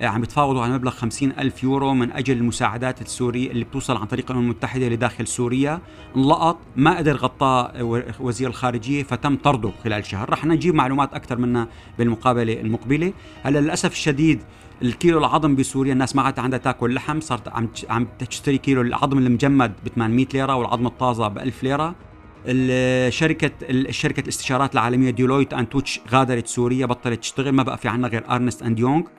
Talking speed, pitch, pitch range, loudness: 165 wpm, 130 Hz, 120-135 Hz, -21 LUFS